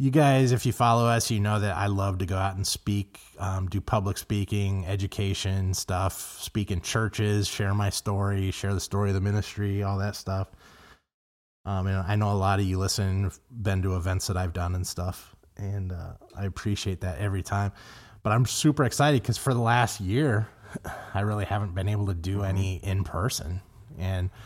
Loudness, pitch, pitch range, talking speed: -27 LUFS, 100 Hz, 95-105 Hz, 200 wpm